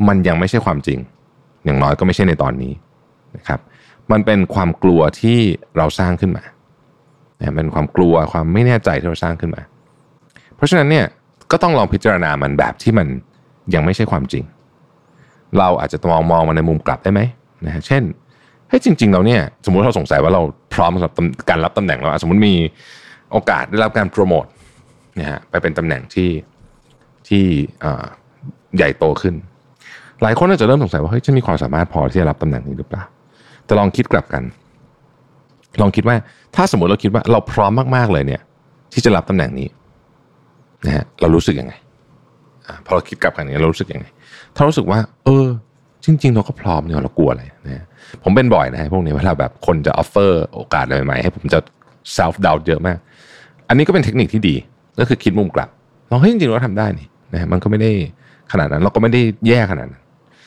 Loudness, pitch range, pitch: -16 LUFS, 80-125 Hz, 100 Hz